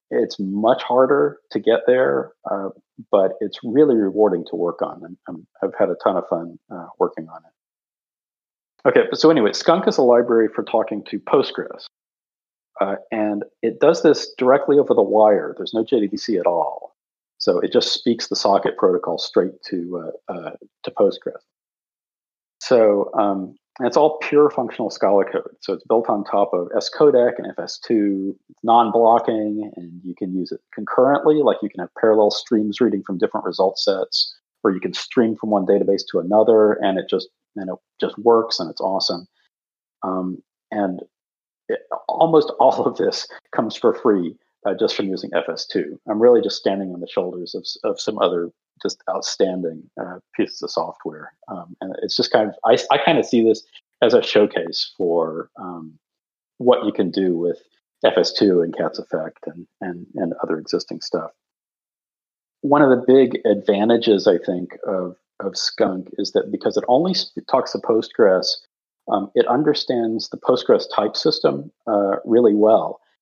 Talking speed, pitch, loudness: 175 wpm, 120 Hz, -19 LUFS